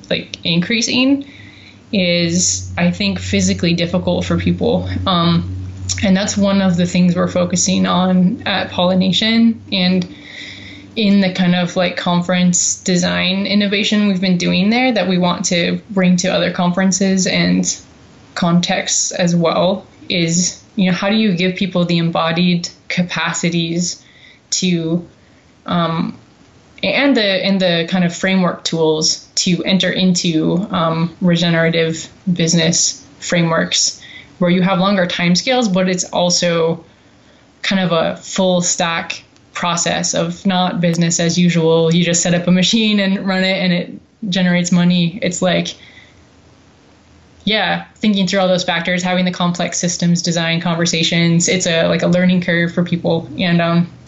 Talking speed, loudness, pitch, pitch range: 145 wpm, -15 LUFS, 180 Hz, 170-185 Hz